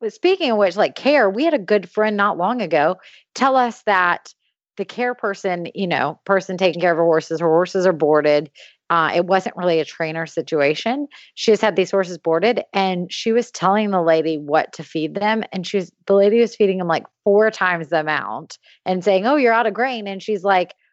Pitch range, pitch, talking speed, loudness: 170-220 Hz, 195 Hz, 220 wpm, -19 LUFS